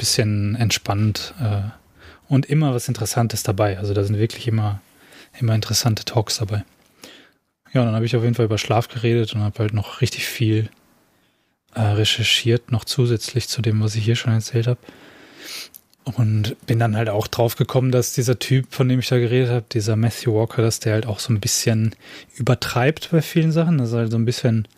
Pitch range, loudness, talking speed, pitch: 110-125 Hz, -20 LUFS, 195 wpm, 115 Hz